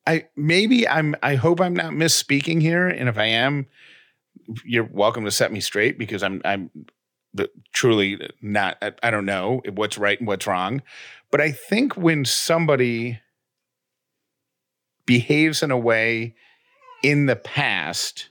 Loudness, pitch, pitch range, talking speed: -21 LUFS, 135 Hz, 115-160 Hz, 150 wpm